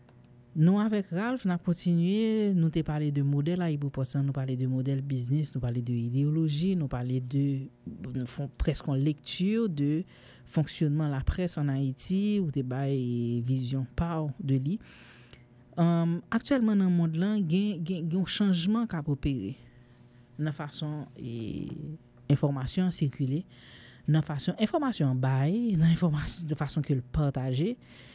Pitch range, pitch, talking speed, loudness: 130-175 Hz, 150 Hz, 140 wpm, -29 LUFS